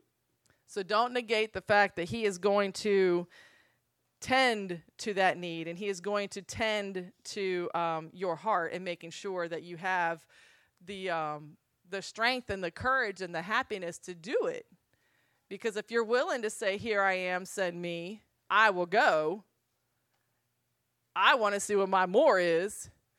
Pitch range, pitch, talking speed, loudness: 170-205 Hz, 190 Hz, 170 wpm, -30 LUFS